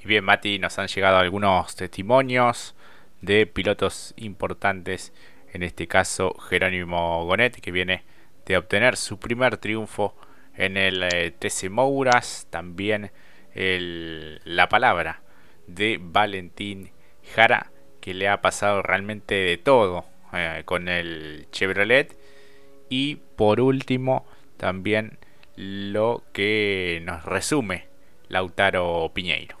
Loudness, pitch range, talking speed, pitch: -23 LUFS, 90-105 Hz, 110 wpm, 95 Hz